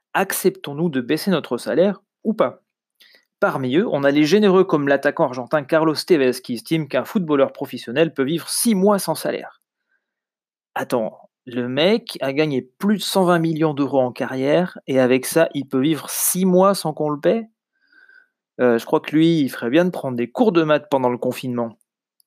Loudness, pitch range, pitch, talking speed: -19 LUFS, 130-185 Hz, 155 Hz, 190 wpm